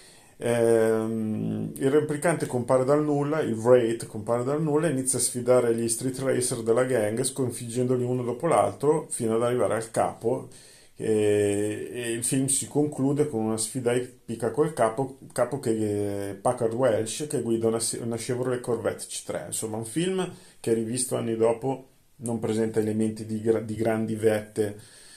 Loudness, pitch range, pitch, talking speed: -26 LUFS, 110-130 Hz, 120 Hz, 160 wpm